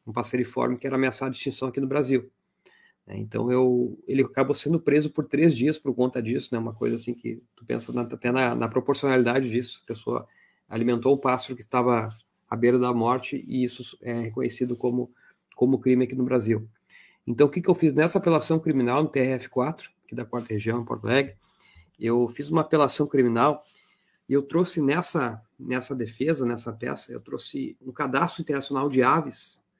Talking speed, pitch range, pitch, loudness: 190 wpm, 120-140 Hz, 130 Hz, -25 LUFS